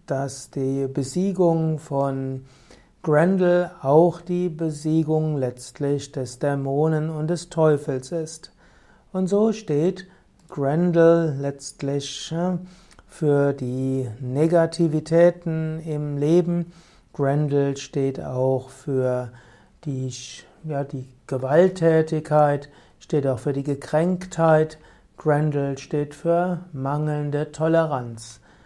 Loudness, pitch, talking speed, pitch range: -23 LUFS, 150 Hz, 90 wpm, 135-165 Hz